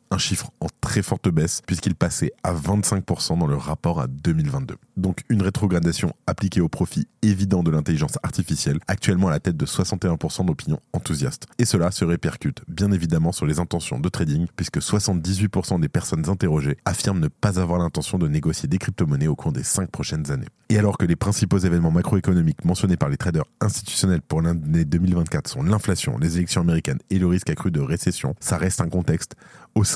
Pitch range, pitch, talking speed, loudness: 85-100 Hz, 90 Hz, 190 wpm, -22 LUFS